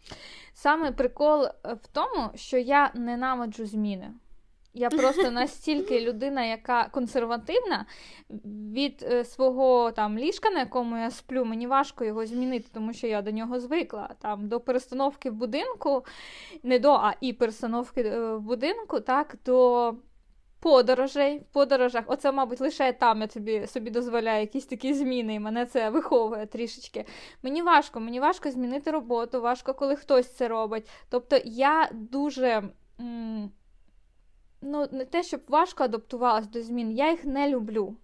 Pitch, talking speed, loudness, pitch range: 250 Hz, 145 wpm, -27 LUFS, 235-275 Hz